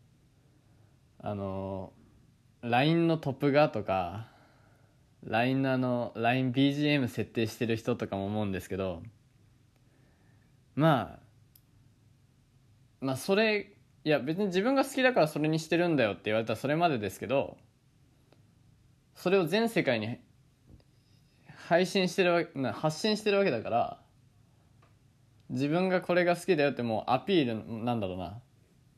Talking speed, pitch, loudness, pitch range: 260 characters per minute, 130 Hz, -29 LUFS, 115-150 Hz